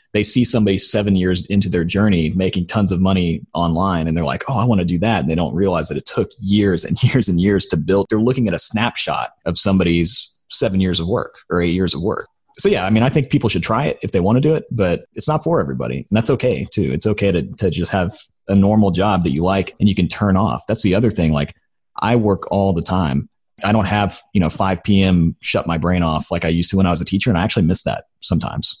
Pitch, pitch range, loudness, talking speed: 95 Hz, 85-105 Hz, -16 LUFS, 270 wpm